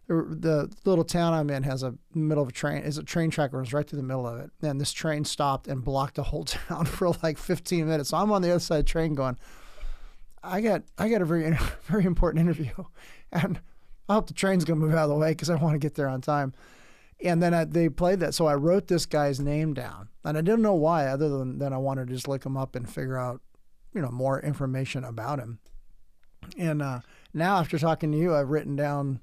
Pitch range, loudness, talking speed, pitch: 135-165 Hz, -27 LUFS, 250 wpm, 150 Hz